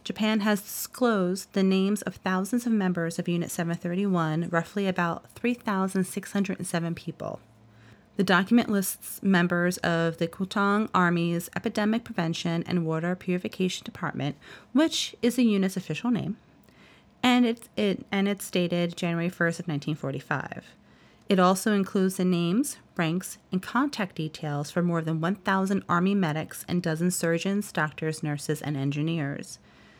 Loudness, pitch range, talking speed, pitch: -27 LUFS, 170-200 Hz, 140 wpm, 185 Hz